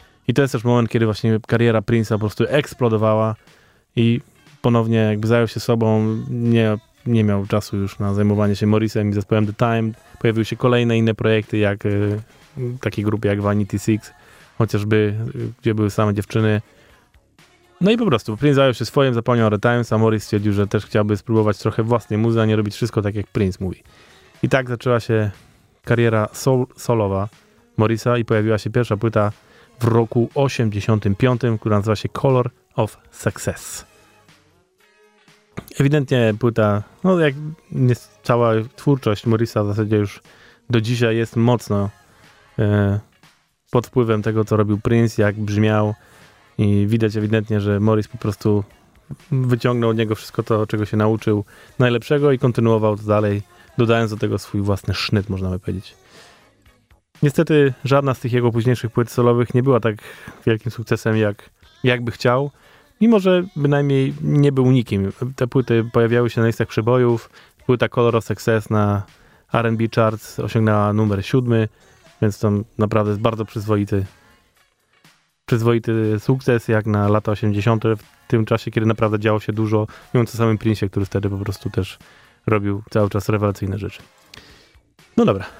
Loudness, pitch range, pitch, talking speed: -19 LUFS, 105-120 Hz, 110 Hz, 160 wpm